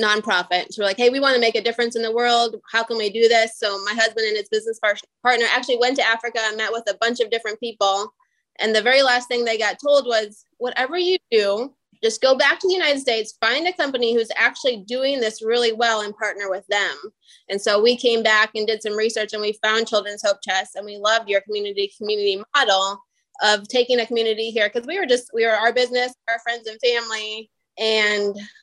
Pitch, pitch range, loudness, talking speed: 230 Hz, 215-250 Hz, -20 LUFS, 235 wpm